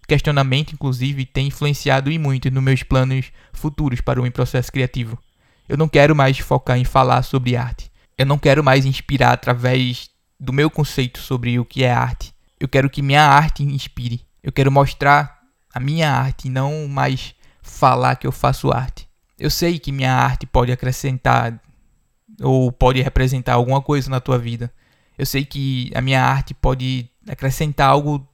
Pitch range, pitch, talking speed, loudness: 125-140 Hz, 135 Hz, 170 wpm, -18 LUFS